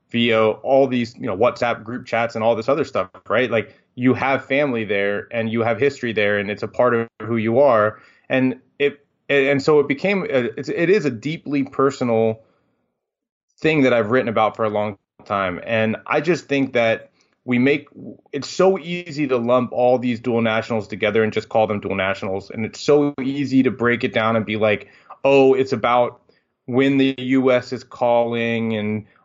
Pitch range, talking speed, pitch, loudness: 110-135 Hz, 195 wpm, 120 Hz, -19 LUFS